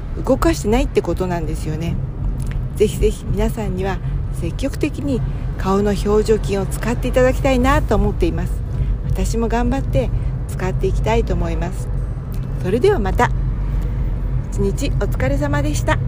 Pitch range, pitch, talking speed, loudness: 125-155 Hz, 130 Hz, 325 characters per minute, -20 LUFS